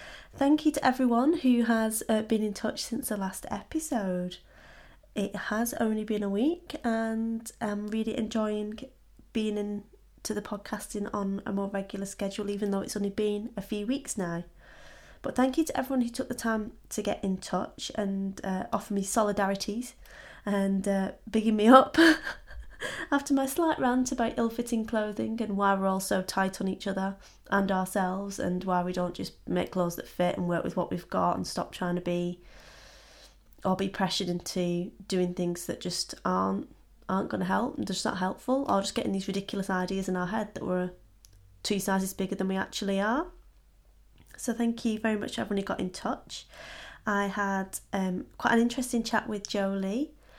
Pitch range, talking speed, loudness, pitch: 190-230 Hz, 190 wpm, -30 LUFS, 205 Hz